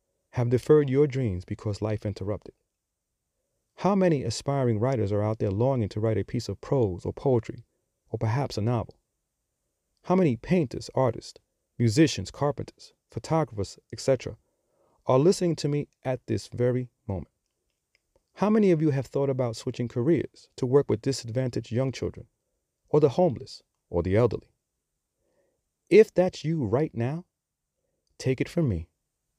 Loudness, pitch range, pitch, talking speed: -26 LUFS, 110-150 Hz, 125 Hz, 150 wpm